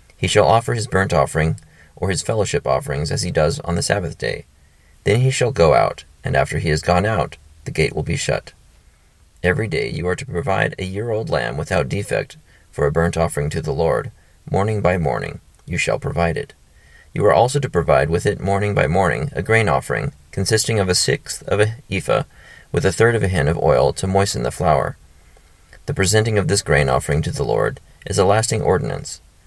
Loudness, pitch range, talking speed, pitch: -19 LUFS, 80-105 Hz, 210 wpm, 90 Hz